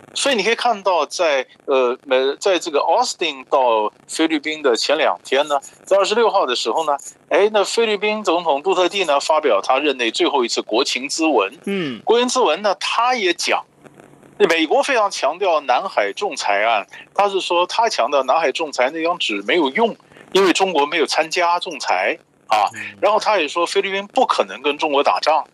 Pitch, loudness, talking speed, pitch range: 190 Hz, -18 LUFS, 285 characters per minute, 155-230 Hz